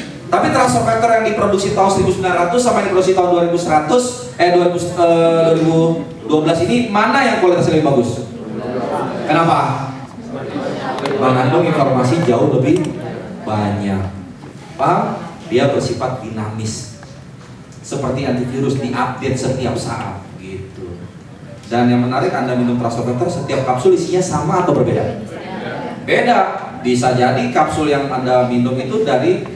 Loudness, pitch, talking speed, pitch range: -15 LUFS, 140 Hz, 120 wpm, 125-175 Hz